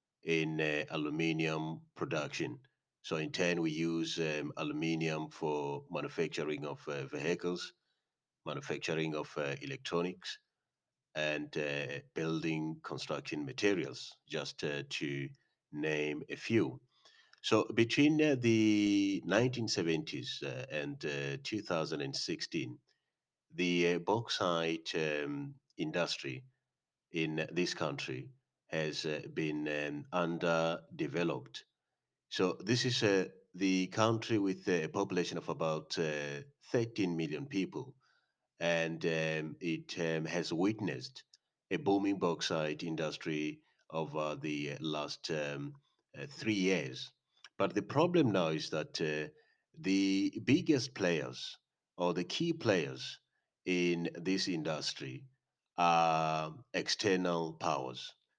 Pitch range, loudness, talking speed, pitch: 75-95 Hz, -35 LUFS, 110 wpm, 80 Hz